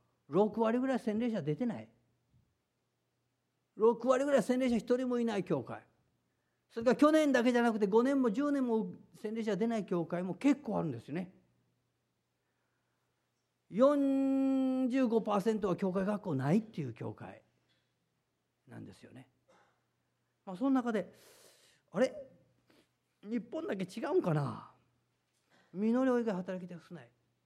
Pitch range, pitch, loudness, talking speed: 155-250 Hz, 215 Hz, -33 LUFS, 235 characters per minute